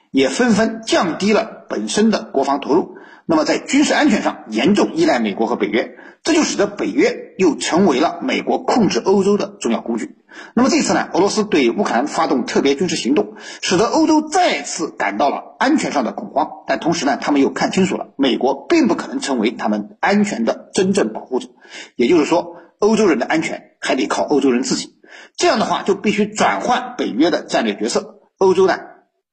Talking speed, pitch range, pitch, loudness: 310 characters per minute, 205-330 Hz, 240 Hz, -17 LUFS